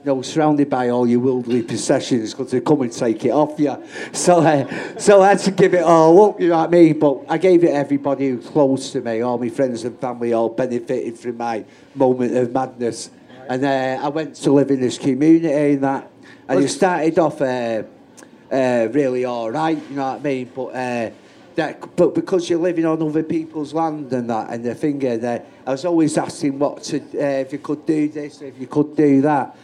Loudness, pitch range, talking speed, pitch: -18 LUFS, 125-155 Hz, 235 wpm, 140 Hz